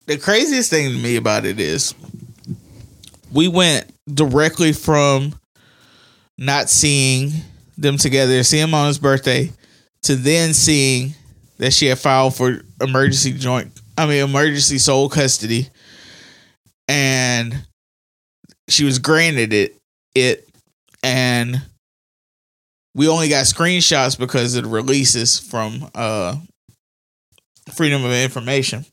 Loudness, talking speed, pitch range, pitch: -16 LUFS, 115 wpm, 125-150 Hz, 135 Hz